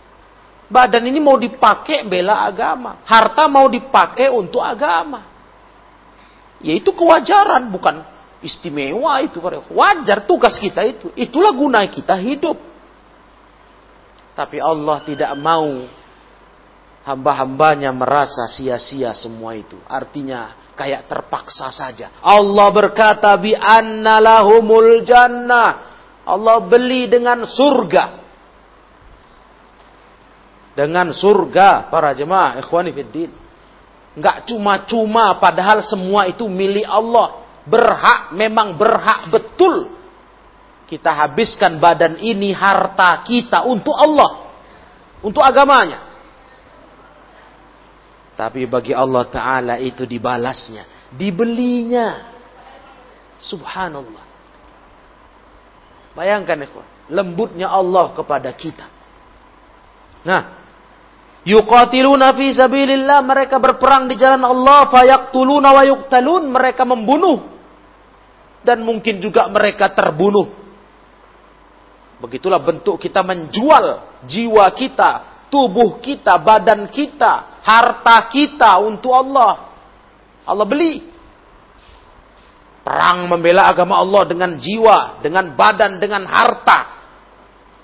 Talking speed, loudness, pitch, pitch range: 85 wpm, -13 LUFS, 215 Hz, 170-255 Hz